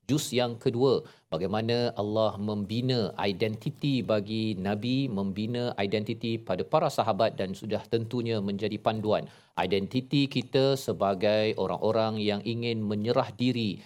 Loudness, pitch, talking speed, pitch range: -29 LUFS, 110 Hz, 115 wpm, 105-125 Hz